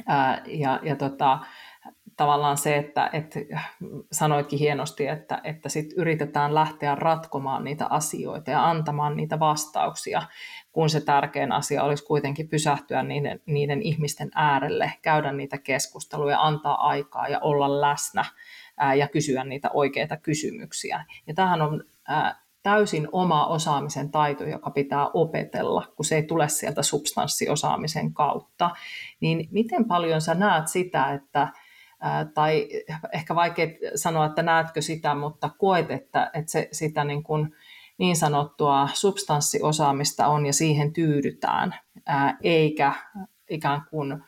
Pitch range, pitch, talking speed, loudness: 145-160 Hz, 150 Hz, 130 wpm, -25 LUFS